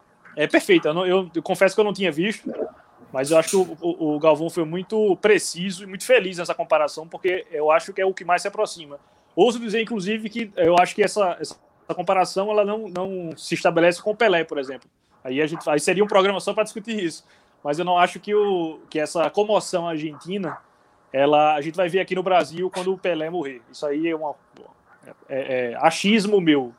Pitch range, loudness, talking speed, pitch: 155-200 Hz, -22 LUFS, 220 wpm, 180 Hz